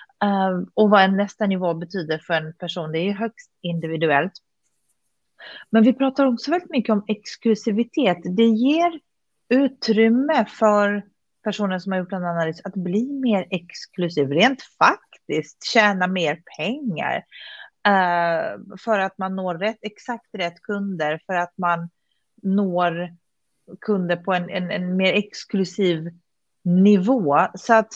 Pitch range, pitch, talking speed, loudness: 175-225 Hz, 200 Hz, 135 wpm, -21 LUFS